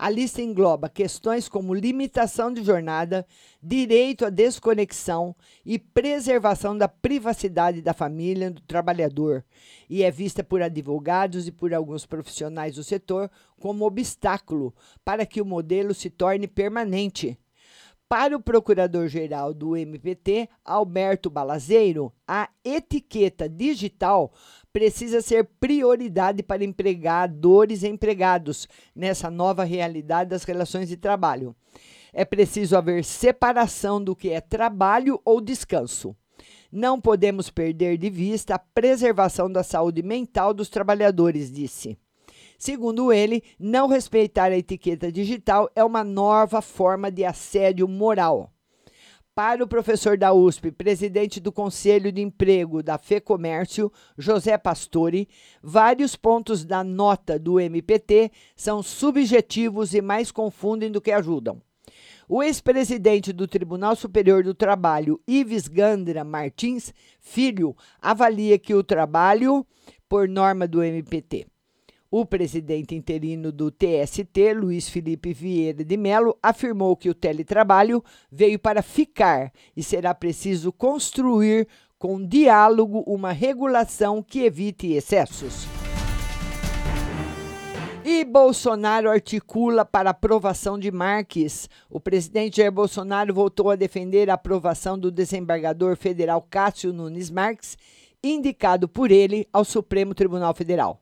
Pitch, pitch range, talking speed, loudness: 200 Hz, 175-220 Hz, 120 wpm, -22 LUFS